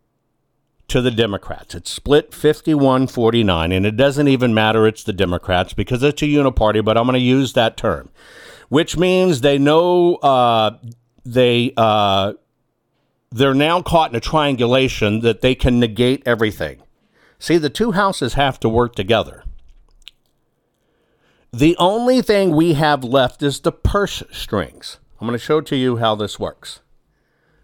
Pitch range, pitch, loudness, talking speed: 115-150 Hz, 130 Hz, -16 LUFS, 150 wpm